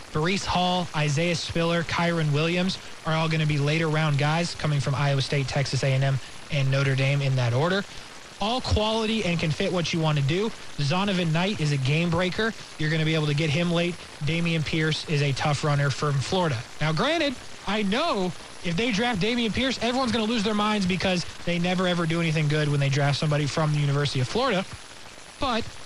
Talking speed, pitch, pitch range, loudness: 210 wpm, 160 Hz, 145-185 Hz, -25 LUFS